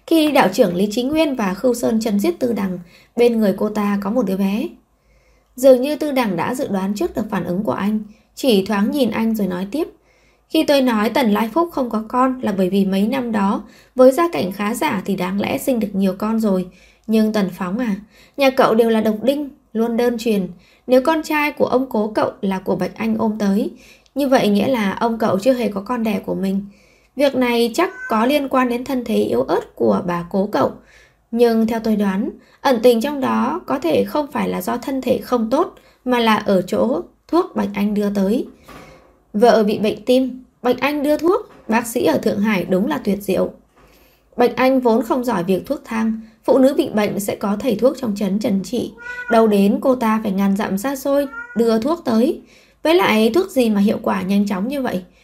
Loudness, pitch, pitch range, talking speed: -18 LUFS, 230 Hz, 205-260 Hz, 230 wpm